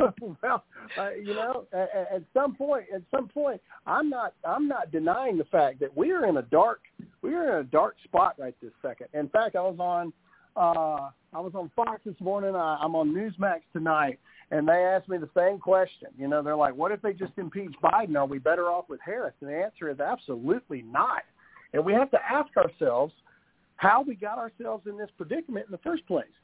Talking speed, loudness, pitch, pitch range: 215 wpm, -28 LUFS, 195 Hz, 170-235 Hz